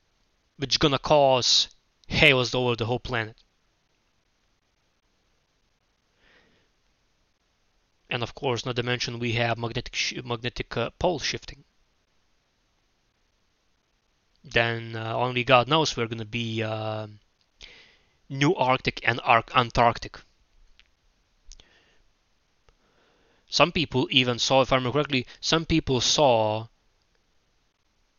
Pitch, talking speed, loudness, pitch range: 120 Hz, 105 wpm, -24 LUFS, 110-130 Hz